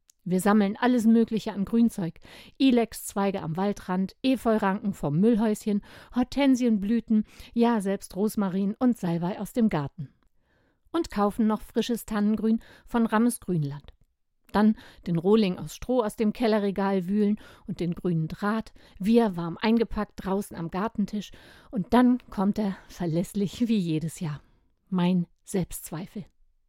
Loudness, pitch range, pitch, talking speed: -26 LUFS, 185-225 Hz, 205 Hz, 130 wpm